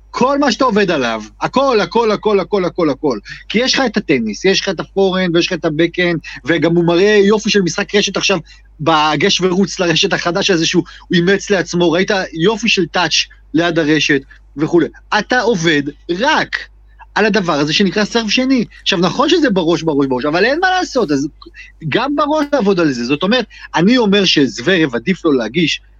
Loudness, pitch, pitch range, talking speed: -14 LUFS, 185 Hz, 165-210 Hz, 185 wpm